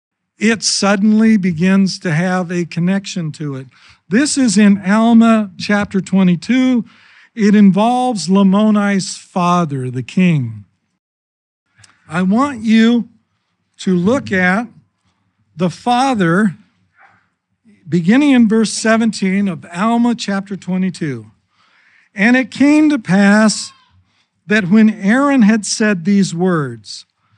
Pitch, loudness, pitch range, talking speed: 195 Hz, -14 LUFS, 175-220 Hz, 105 wpm